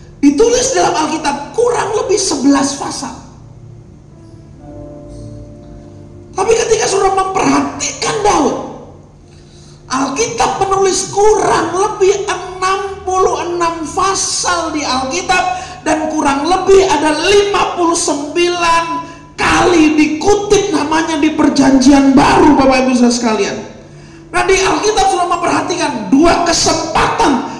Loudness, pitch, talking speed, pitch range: -12 LUFS, 350 Hz, 90 wpm, 305-390 Hz